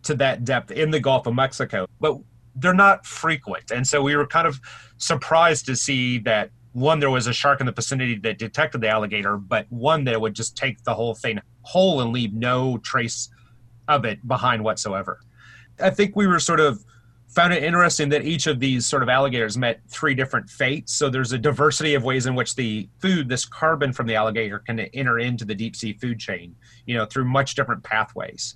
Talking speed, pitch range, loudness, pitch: 215 wpm, 115-145 Hz, -22 LUFS, 125 Hz